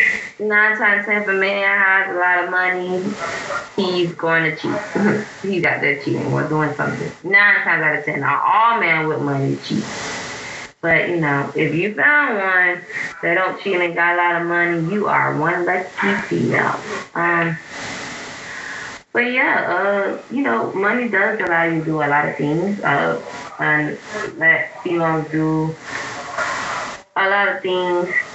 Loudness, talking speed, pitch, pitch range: -18 LUFS, 165 wpm, 175 Hz, 160-200 Hz